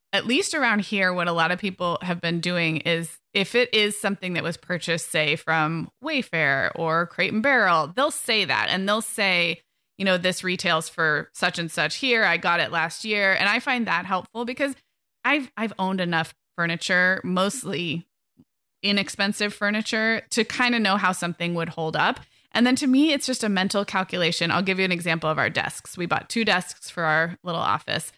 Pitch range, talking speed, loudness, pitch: 170-215 Hz, 200 wpm, -23 LUFS, 185 Hz